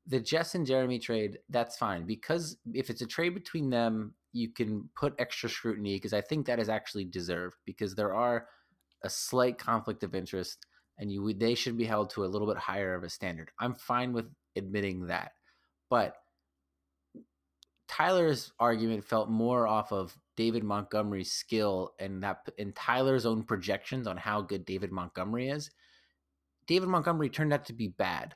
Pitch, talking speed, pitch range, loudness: 110 Hz, 175 wpm, 95-125 Hz, -33 LUFS